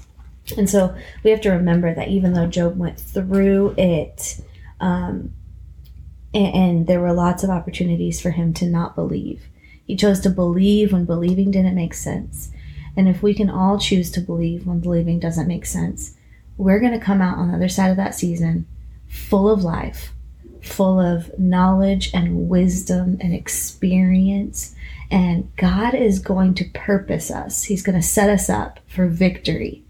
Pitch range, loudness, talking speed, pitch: 170-195 Hz, -19 LUFS, 170 wpm, 180 Hz